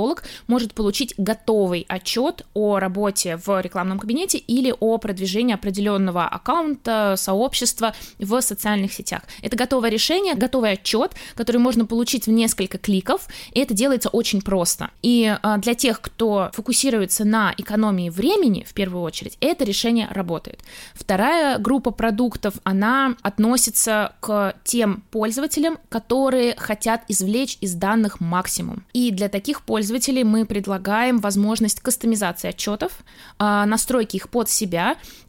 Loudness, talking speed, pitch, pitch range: -21 LUFS, 130 wpm, 220 Hz, 200-245 Hz